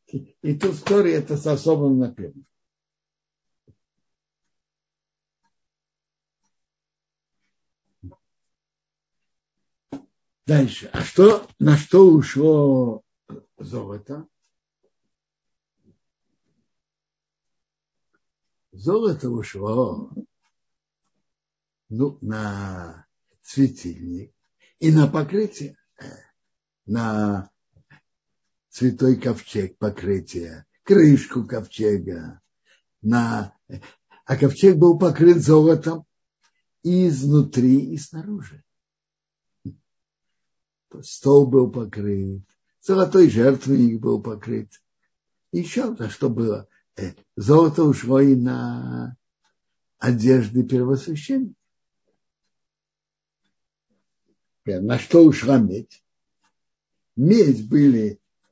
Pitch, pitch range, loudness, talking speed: 135 Hz, 110-155 Hz, -19 LUFS, 65 wpm